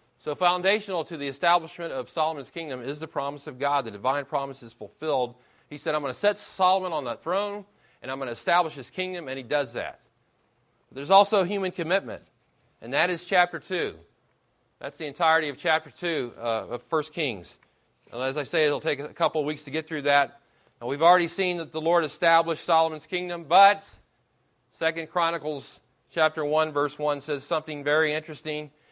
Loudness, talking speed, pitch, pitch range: -26 LUFS, 195 wpm, 155 Hz, 145-175 Hz